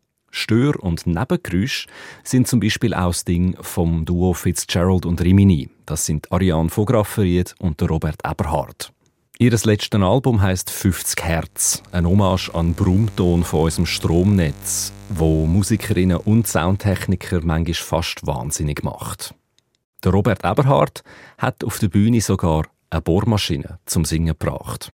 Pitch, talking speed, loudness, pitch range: 90 Hz, 130 wpm, -19 LUFS, 85-105 Hz